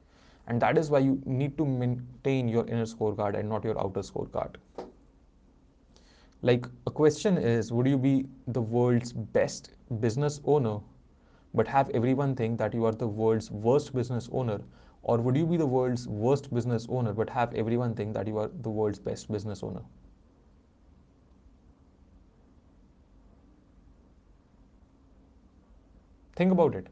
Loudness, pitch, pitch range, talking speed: -29 LUFS, 110 Hz, 80-125 Hz, 145 wpm